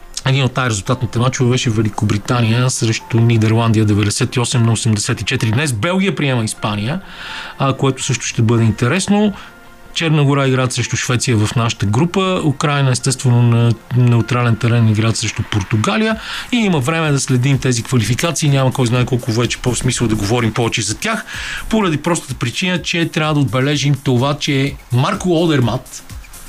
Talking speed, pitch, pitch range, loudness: 150 wpm, 125 Hz, 115-140 Hz, -16 LUFS